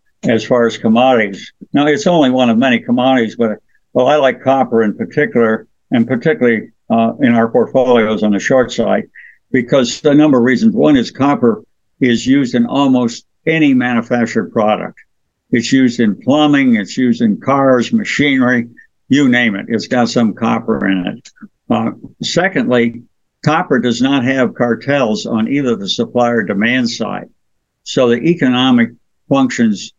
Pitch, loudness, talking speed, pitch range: 130 Hz, -13 LUFS, 160 wpm, 115-170 Hz